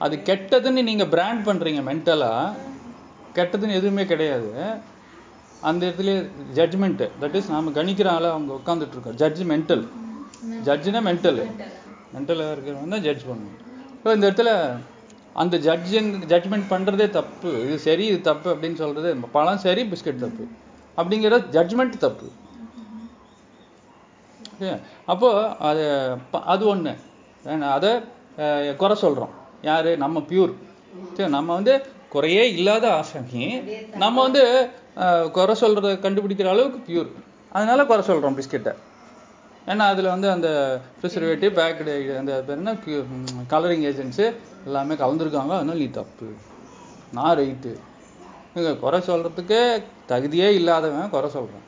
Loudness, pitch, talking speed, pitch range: -22 LUFS, 175 Hz, 110 wpm, 155-215 Hz